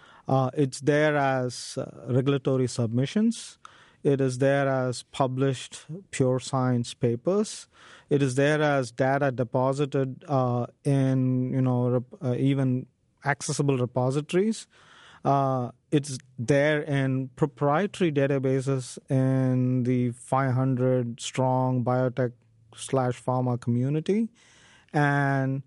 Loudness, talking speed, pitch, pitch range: -26 LUFS, 105 wpm, 130 Hz, 125-140 Hz